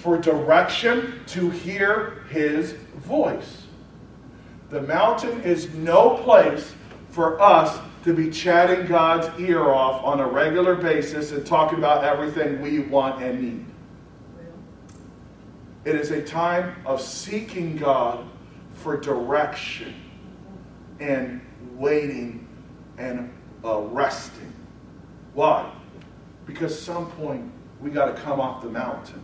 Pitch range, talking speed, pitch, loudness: 140-175 Hz, 115 wpm, 155 Hz, -22 LUFS